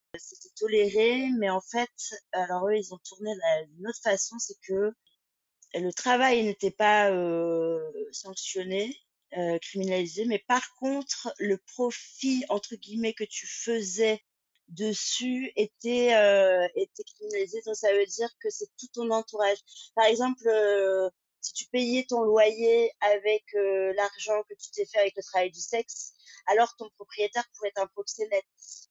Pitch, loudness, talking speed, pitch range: 215 Hz, -28 LUFS, 155 wpm, 200-250 Hz